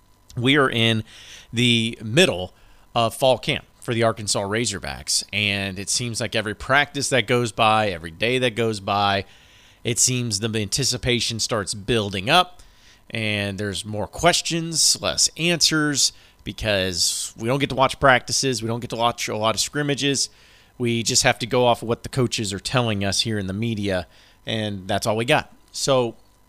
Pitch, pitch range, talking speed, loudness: 115 Hz, 100-125 Hz, 175 wpm, -21 LUFS